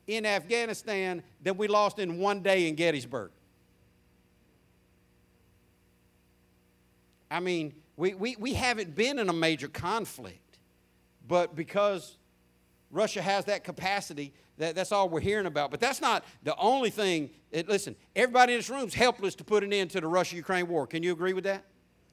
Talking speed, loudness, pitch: 165 wpm, -29 LUFS, 175 Hz